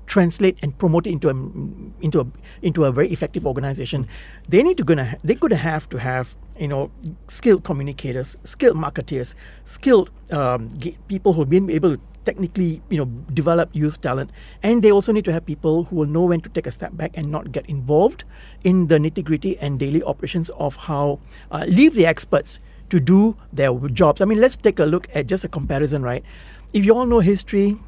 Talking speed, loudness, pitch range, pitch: 200 wpm, -20 LUFS, 140-185 Hz, 160 Hz